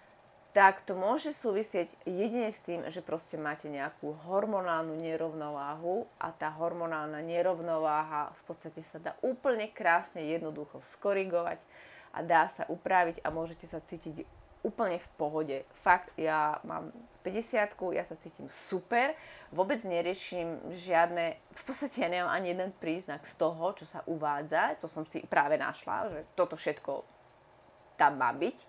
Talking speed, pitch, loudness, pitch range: 145 wpm, 170 Hz, -33 LUFS, 155-195 Hz